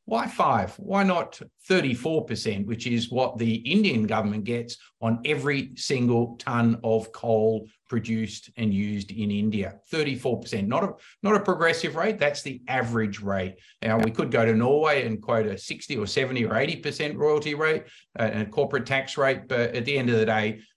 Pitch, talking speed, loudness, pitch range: 120 Hz, 180 wpm, -25 LUFS, 110-145 Hz